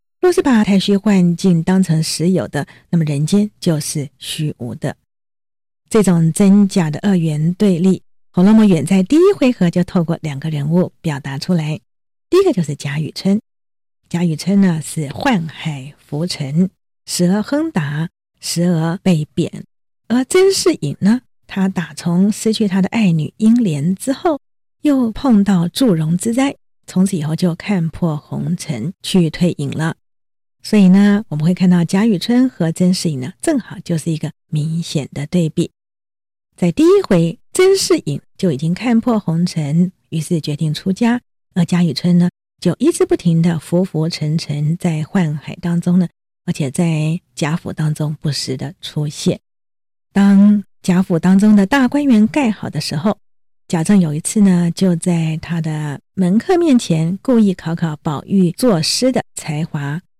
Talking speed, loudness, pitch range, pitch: 230 characters per minute, -16 LUFS, 155-200 Hz, 175 Hz